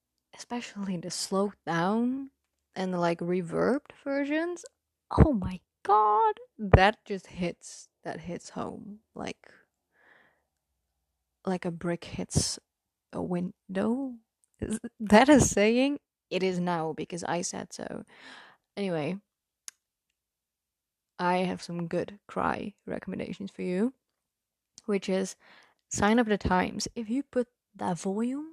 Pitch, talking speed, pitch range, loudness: 200 Hz, 120 wpm, 180-235 Hz, -29 LUFS